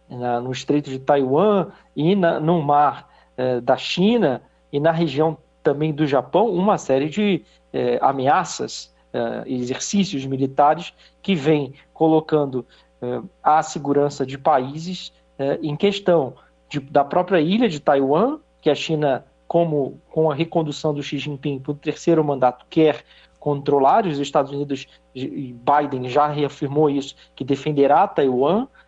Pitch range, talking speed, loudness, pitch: 135-160 Hz, 145 wpm, -20 LUFS, 145 Hz